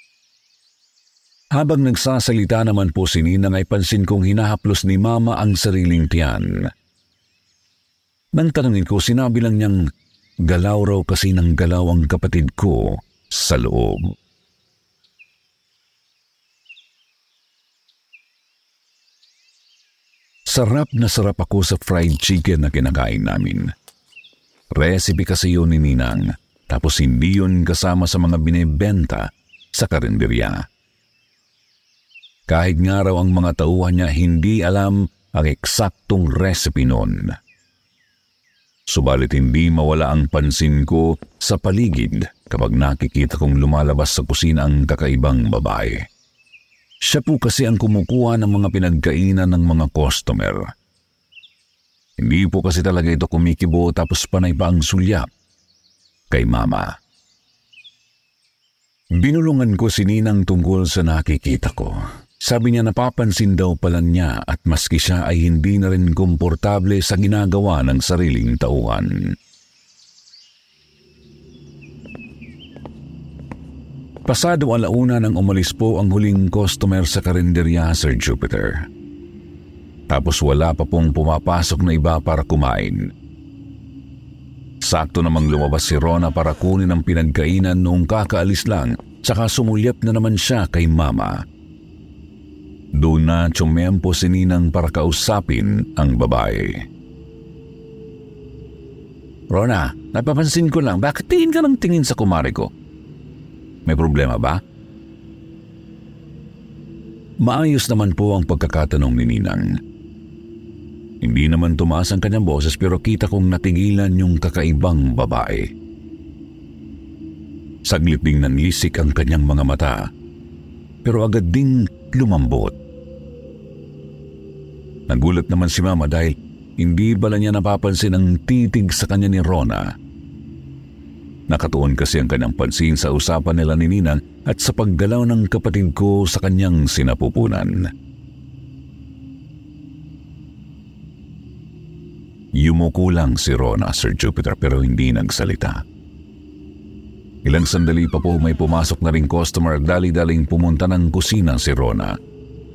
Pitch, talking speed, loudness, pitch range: 85 Hz, 115 wpm, -17 LUFS, 75-100 Hz